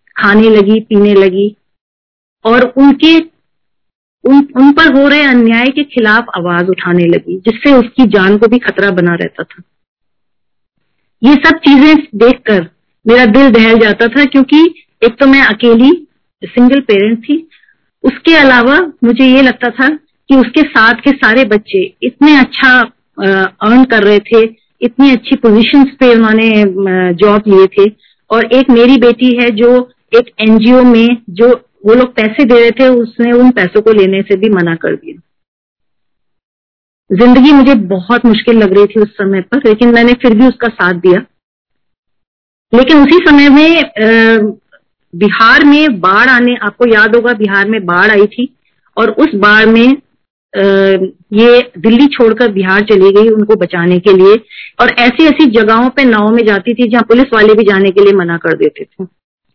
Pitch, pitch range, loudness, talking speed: 235 Hz, 205-260 Hz, -7 LUFS, 165 wpm